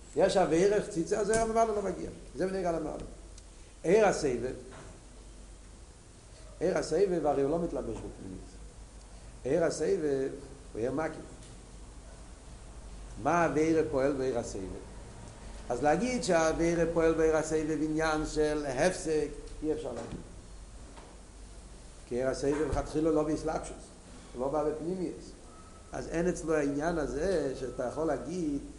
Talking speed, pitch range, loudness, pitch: 100 wpm, 110-165 Hz, -31 LUFS, 155 Hz